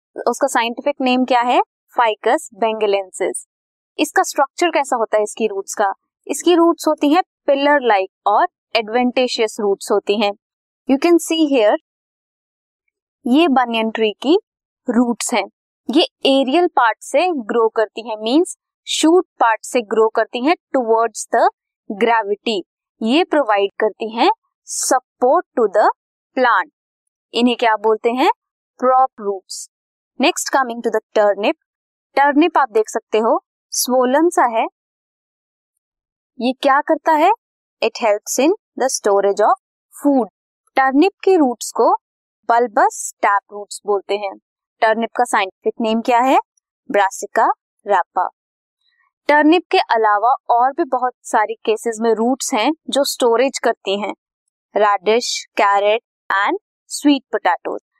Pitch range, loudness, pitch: 225-325 Hz, -17 LUFS, 255 Hz